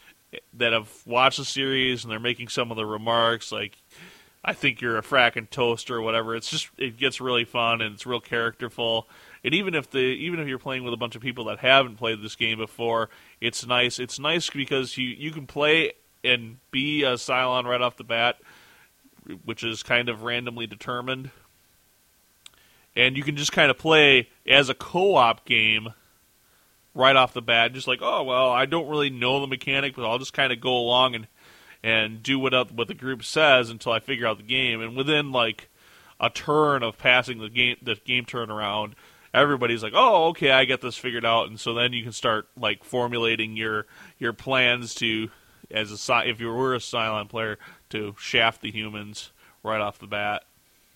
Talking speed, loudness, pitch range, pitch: 200 wpm, -23 LUFS, 115-130 Hz, 120 Hz